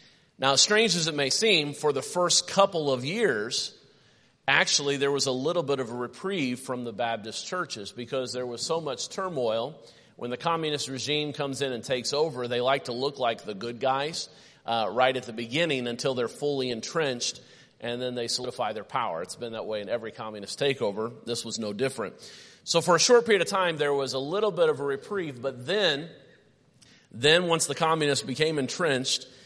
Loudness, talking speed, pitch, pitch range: -27 LUFS, 200 wpm, 135 Hz, 120-160 Hz